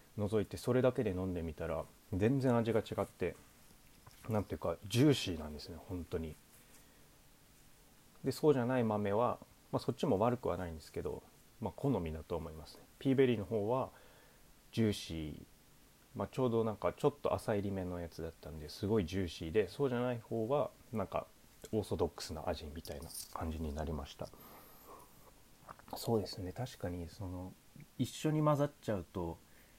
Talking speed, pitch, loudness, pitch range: 350 characters per minute, 95 Hz, -37 LUFS, 80-120 Hz